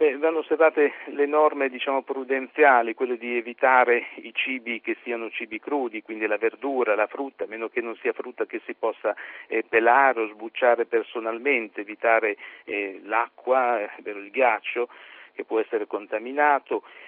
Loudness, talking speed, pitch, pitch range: -24 LUFS, 155 wpm, 130 Hz, 115-150 Hz